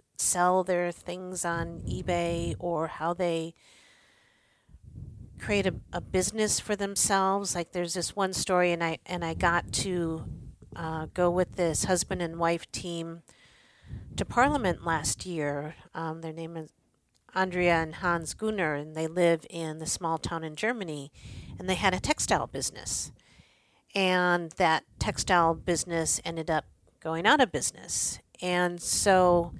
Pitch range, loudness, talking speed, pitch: 160-180 Hz, -28 LUFS, 145 wpm, 170 Hz